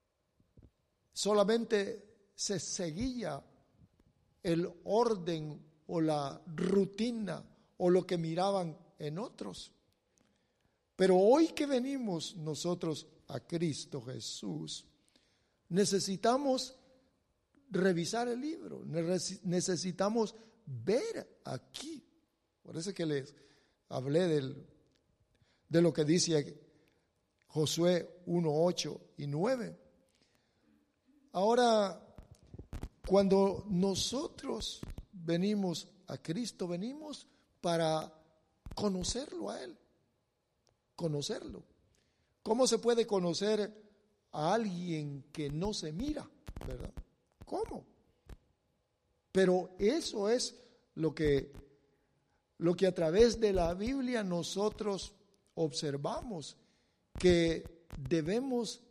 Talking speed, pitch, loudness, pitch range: 85 wpm, 185 Hz, -34 LUFS, 160-225 Hz